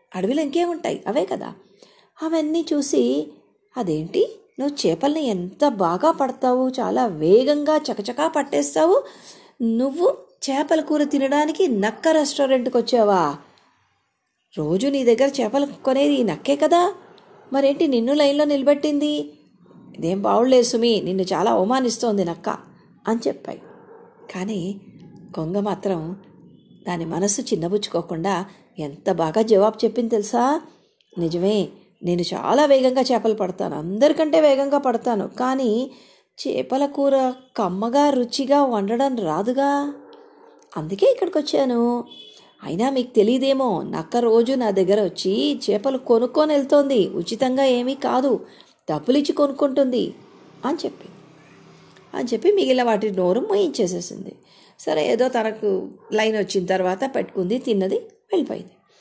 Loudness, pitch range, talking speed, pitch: -21 LUFS, 205-285 Hz, 110 wpm, 250 Hz